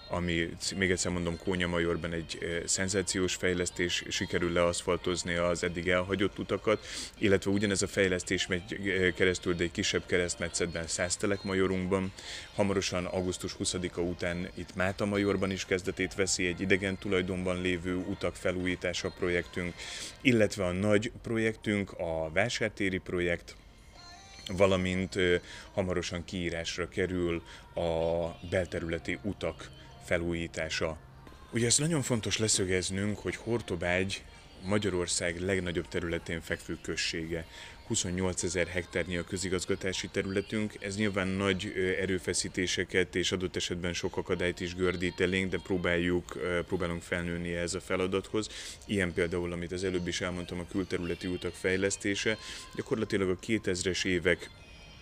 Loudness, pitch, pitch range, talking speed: -31 LUFS, 90 Hz, 85-95 Hz, 120 wpm